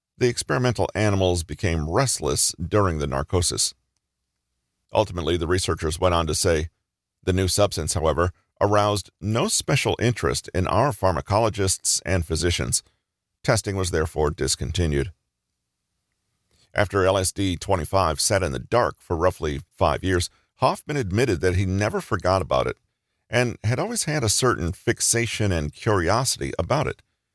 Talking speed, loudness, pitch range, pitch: 135 wpm, -23 LUFS, 80-105 Hz, 95 Hz